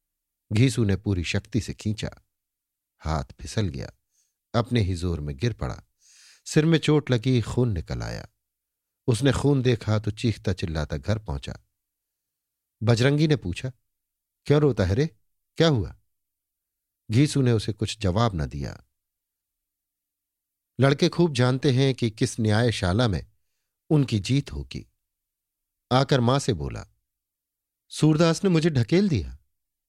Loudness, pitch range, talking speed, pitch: -24 LUFS, 90-130 Hz, 135 wpm, 105 Hz